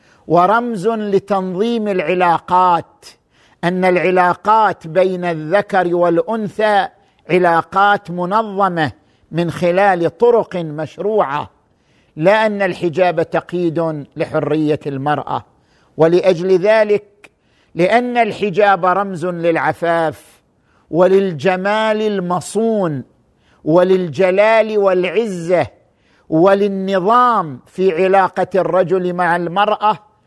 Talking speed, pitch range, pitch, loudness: 70 wpm, 170-205 Hz, 185 Hz, -15 LUFS